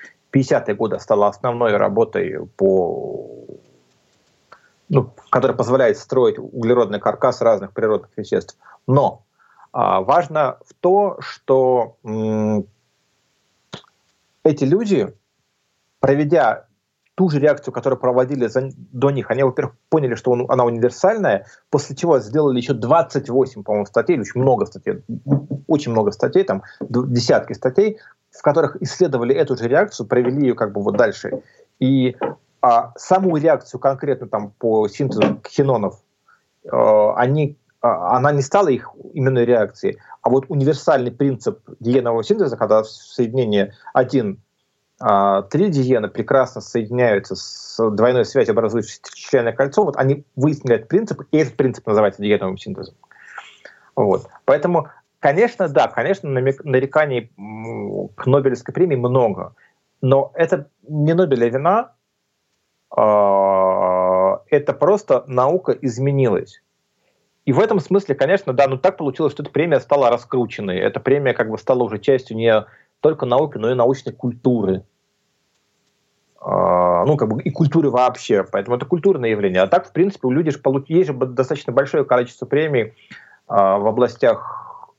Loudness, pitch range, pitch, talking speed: -18 LUFS, 115-145 Hz, 130 Hz, 130 wpm